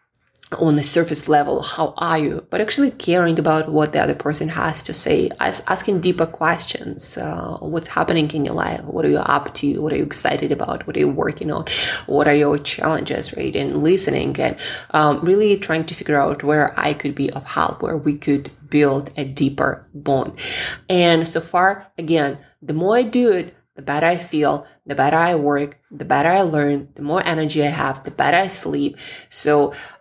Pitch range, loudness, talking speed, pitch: 145-170 Hz, -19 LUFS, 200 wpm, 155 Hz